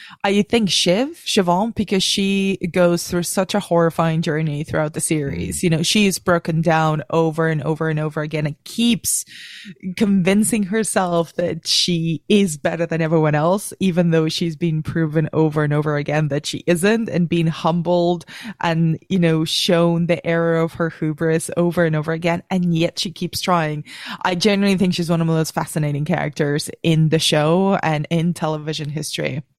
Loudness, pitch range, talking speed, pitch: -19 LUFS, 160-185 Hz, 180 wpm, 170 Hz